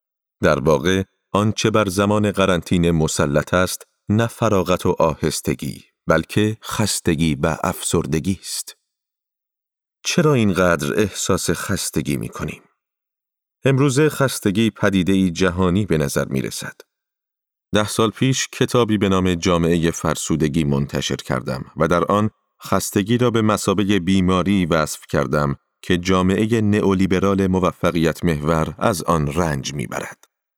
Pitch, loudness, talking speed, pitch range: 95 Hz, -19 LUFS, 120 wpm, 85-105 Hz